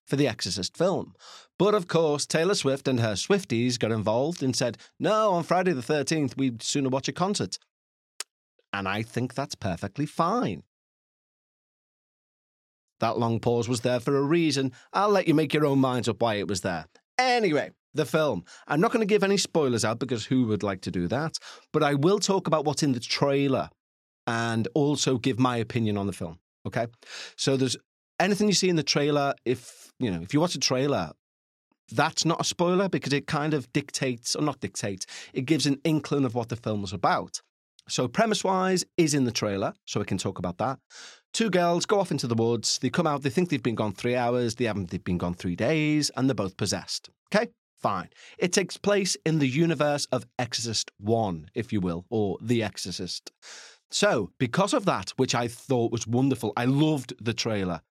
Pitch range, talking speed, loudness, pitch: 110-155 Hz, 205 wpm, -26 LUFS, 130 Hz